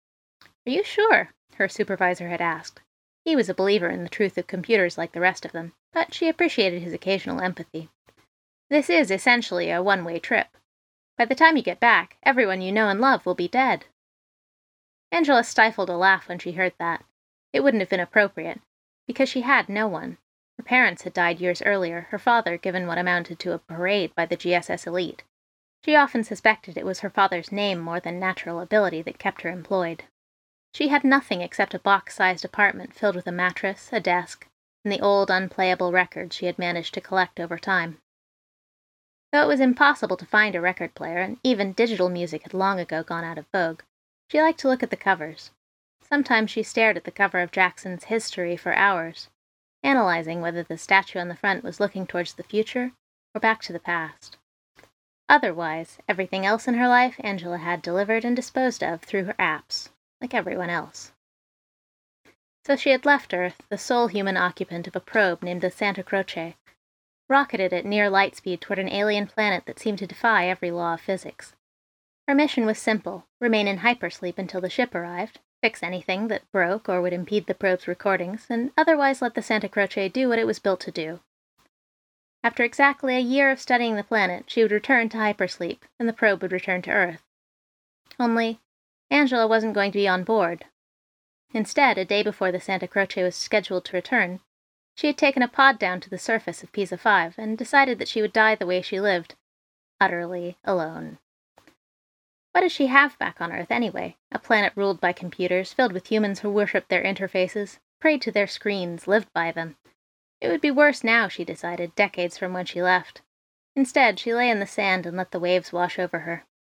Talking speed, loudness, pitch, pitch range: 195 wpm, -23 LUFS, 195 Hz, 180-225 Hz